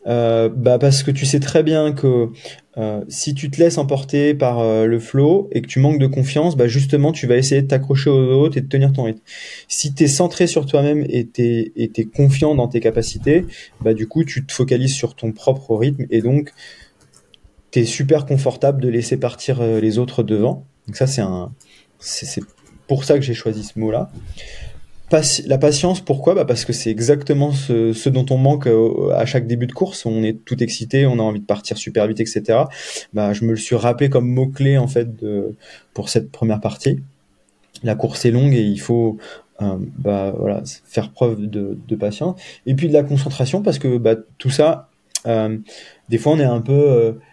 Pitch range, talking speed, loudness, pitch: 115-140 Hz, 215 wpm, -17 LUFS, 125 Hz